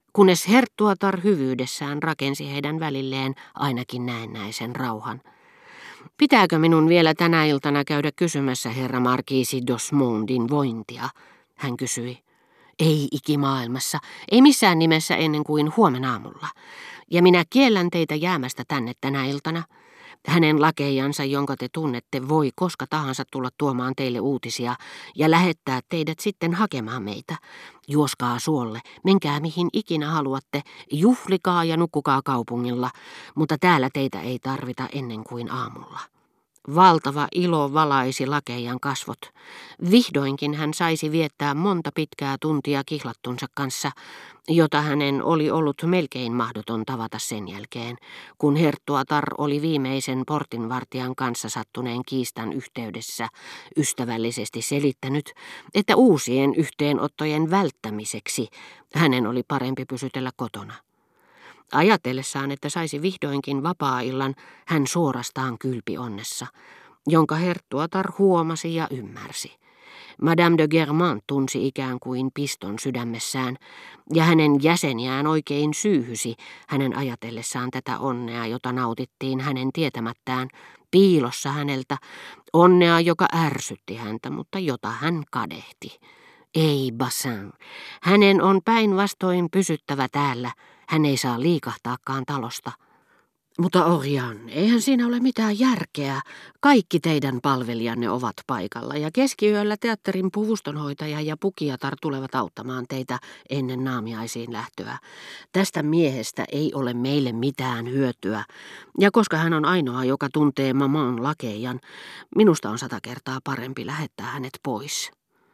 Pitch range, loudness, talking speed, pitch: 130-165 Hz, -23 LUFS, 115 wpm, 140 Hz